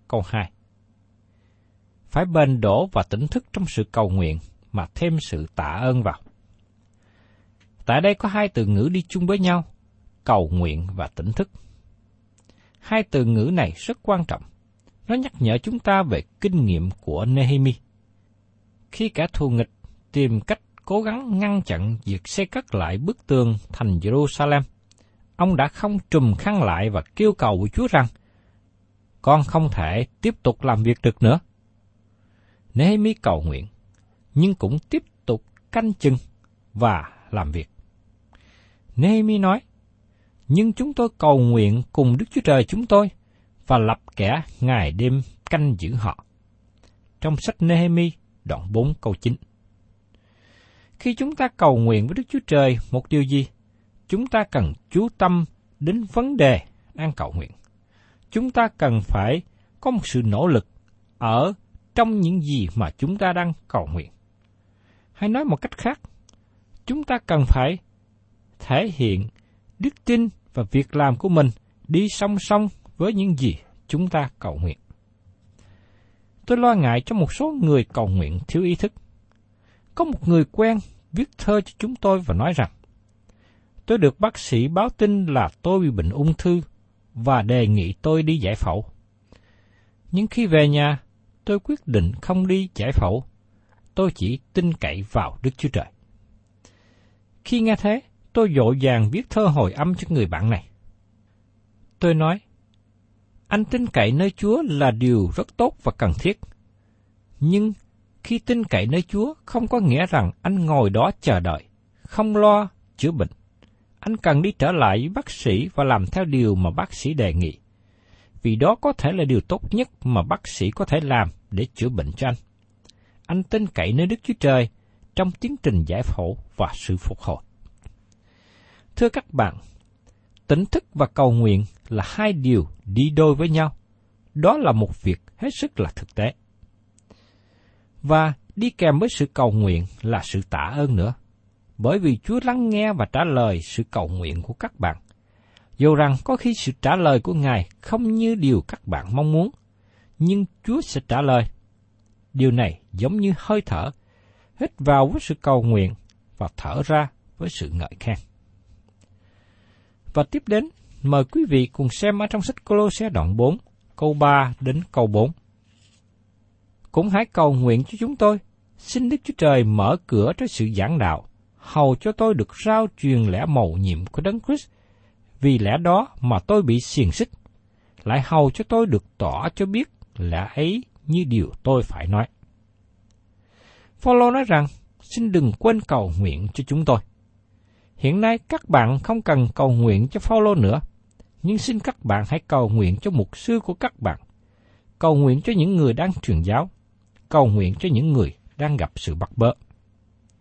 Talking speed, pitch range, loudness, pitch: 170 wpm, 105-170 Hz, -21 LUFS, 115 Hz